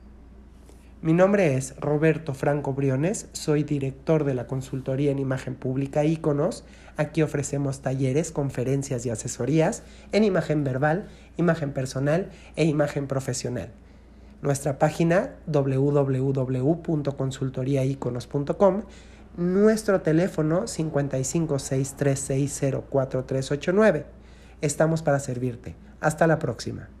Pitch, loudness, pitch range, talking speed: 140 Hz, -25 LUFS, 130-155 Hz, 90 wpm